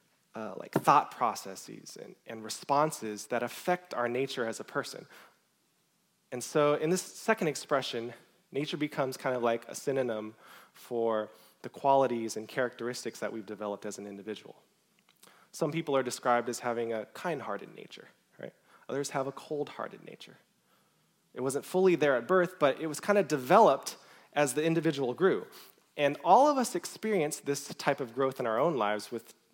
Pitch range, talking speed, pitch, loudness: 115-155 Hz, 170 wpm, 135 Hz, -31 LUFS